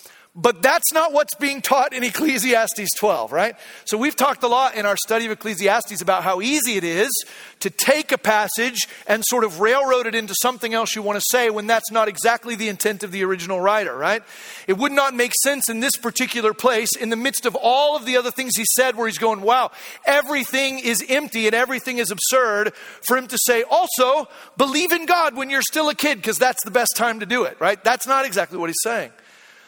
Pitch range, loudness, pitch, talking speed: 215-270 Hz, -19 LUFS, 240 Hz, 225 wpm